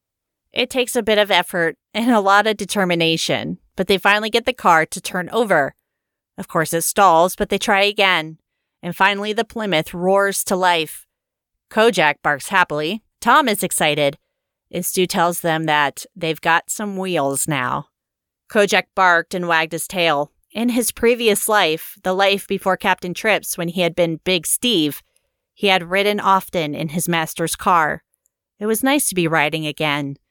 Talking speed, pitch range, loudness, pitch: 170 wpm, 165-210 Hz, -18 LUFS, 185 Hz